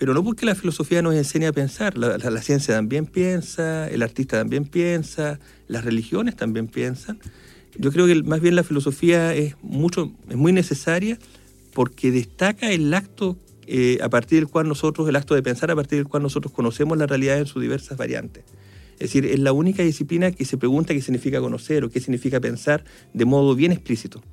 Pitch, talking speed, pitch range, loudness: 145 Hz, 195 wpm, 125-165 Hz, -21 LUFS